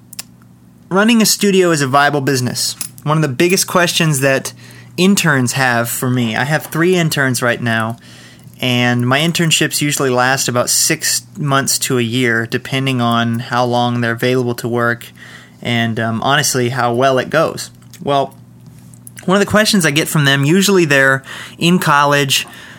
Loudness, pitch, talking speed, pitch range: -14 LUFS, 130 Hz, 165 wpm, 120-155 Hz